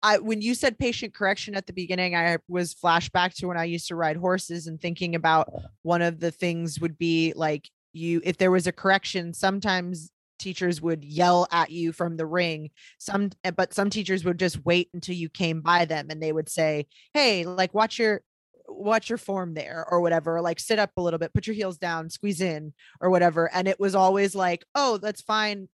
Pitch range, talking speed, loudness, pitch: 165-195 Hz, 215 wpm, -25 LUFS, 180 Hz